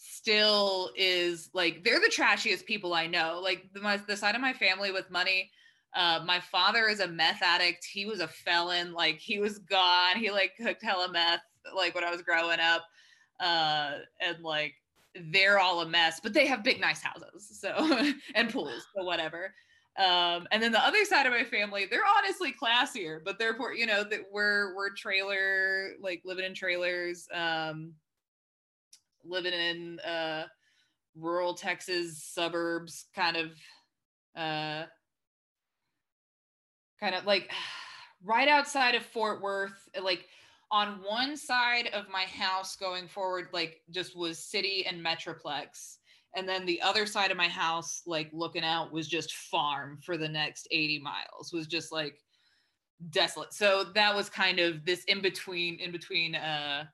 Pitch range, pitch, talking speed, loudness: 165-205 Hz, 185 Hz, 165 wpm, -29 LUFS